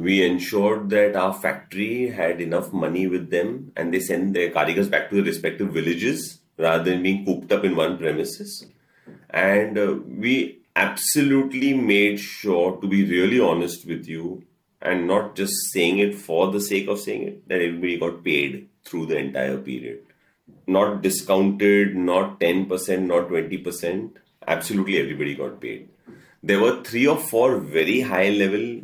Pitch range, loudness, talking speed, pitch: 90-100 Hz, -22 LUFS, 160 wpm, 95 Hz